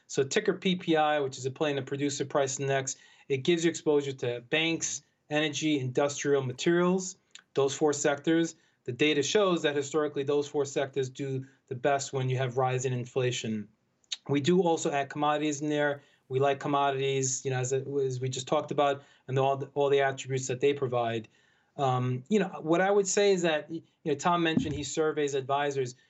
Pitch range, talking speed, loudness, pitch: 135-155 Hz, 195 wpm, -29 LUFS, 145 Hz